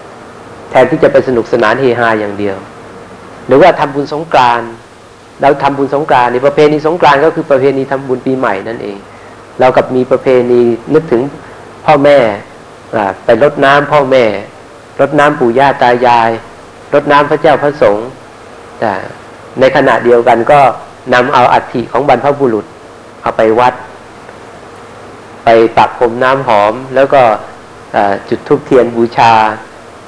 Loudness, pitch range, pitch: -9 LUFS, 115-145 Hz, 130 Hz